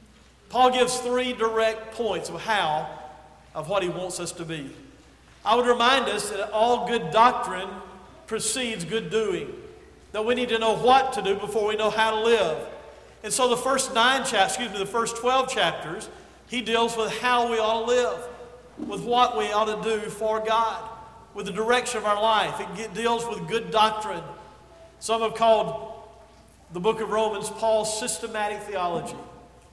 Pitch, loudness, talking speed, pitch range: 220 Hz, -24 LUFS, 180 wpm, 210-240 Hz